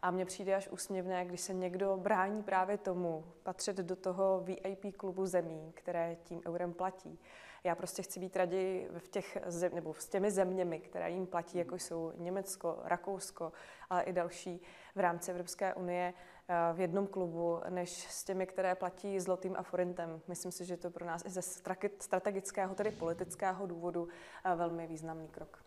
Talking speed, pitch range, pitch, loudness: 170 wpm, 175-190 Hz, 180 Hz, -38 LUFS